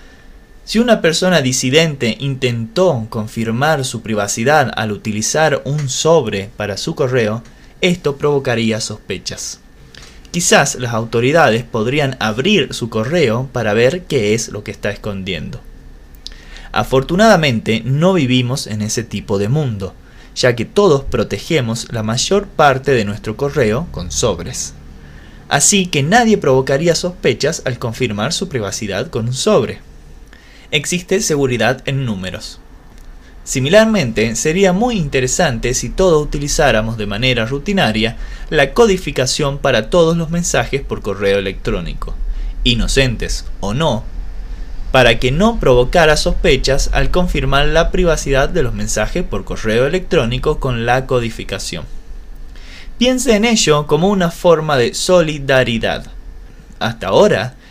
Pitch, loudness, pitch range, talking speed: 125 Hz, -15 LUFS, 105-155 Hz, 125 wpm